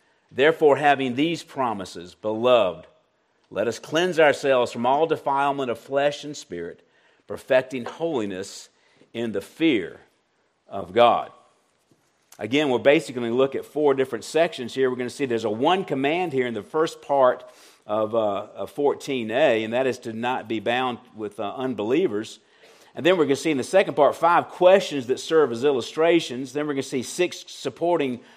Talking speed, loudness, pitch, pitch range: 180 wpm, -23 LUFS, 135 Hz, 120-160 Hz